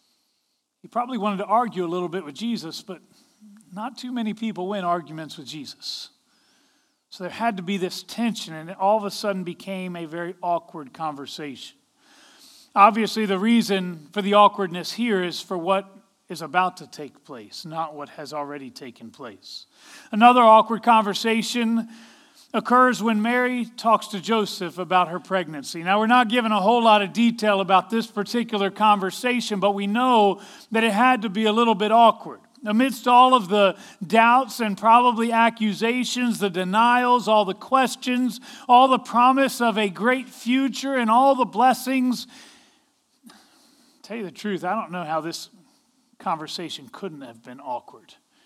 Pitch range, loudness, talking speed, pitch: 190-245 Hz, -21 LUFS, 165 wpm, 220 Hz